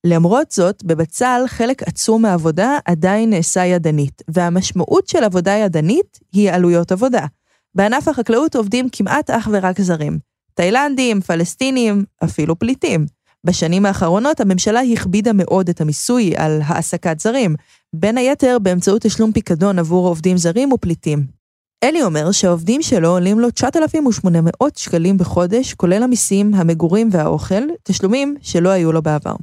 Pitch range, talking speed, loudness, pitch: 170-235 Hz, 130 wpm, -15 LUFS, 195 Hz